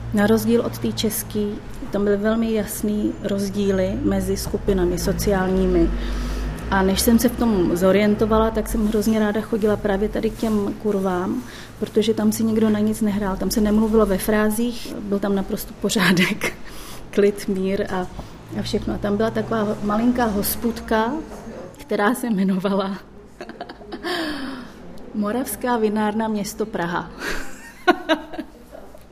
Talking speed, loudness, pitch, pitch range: 130 wpm, -21 LUFS, 210 Hz, 195-225 Hz